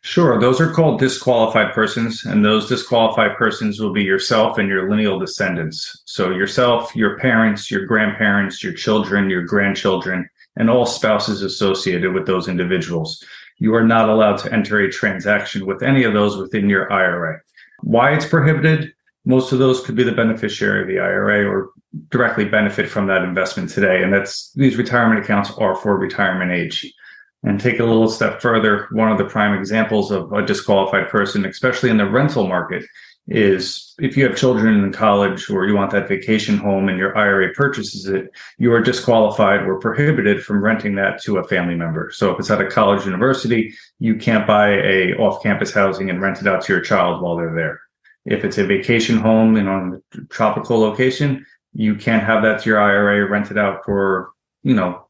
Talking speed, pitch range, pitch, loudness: 190 wpm, 95-120 Hz, 105 Hz, -17 LUFS